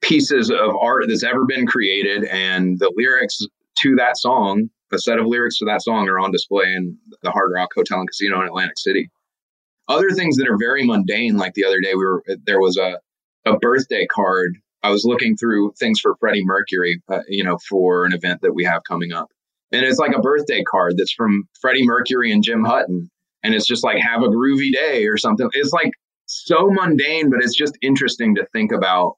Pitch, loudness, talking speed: 120 Hz, -17 LUFS, 215 wpm